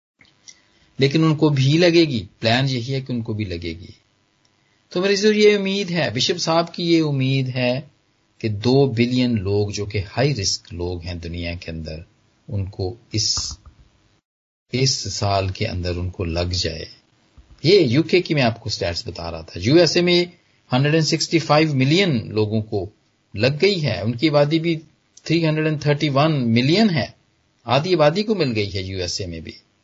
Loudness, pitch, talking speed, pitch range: -20 LUFS, 120 Hz, 155 wpm, 100-155 Hz